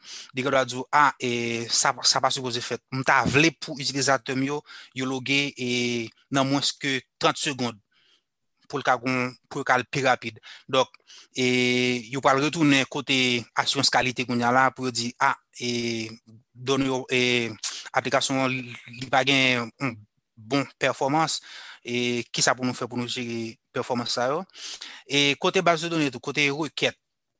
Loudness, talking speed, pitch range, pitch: -24 LUFS, 170 wpm, 120-140 Hz, 130 Hz